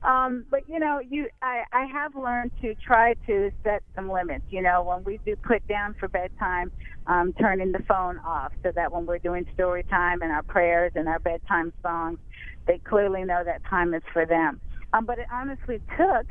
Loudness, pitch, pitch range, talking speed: -26 LUFS, 195 Hz, 175-245 Hz, 205 wpm